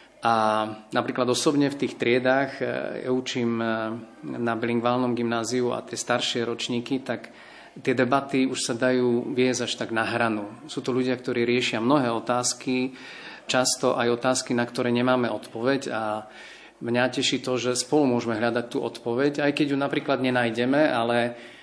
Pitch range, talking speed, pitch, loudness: 120-130 Hz, 155 wpm, 125 Hz, -25 LUFS